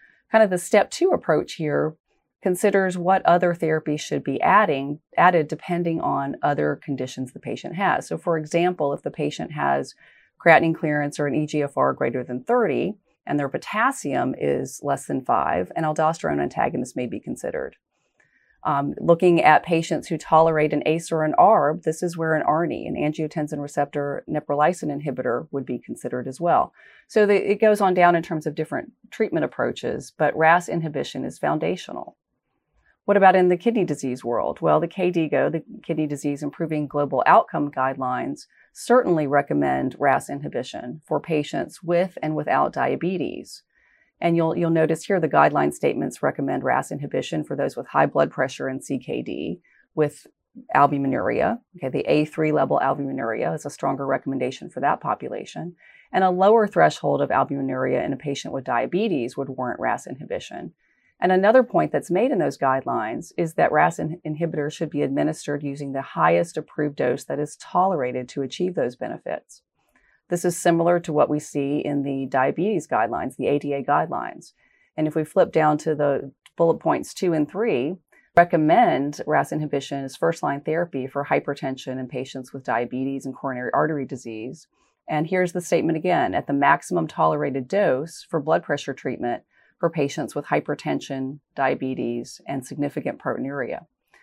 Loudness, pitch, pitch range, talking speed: -23 LUFS, 155 Hz, 140-175 Hz, 165 wpm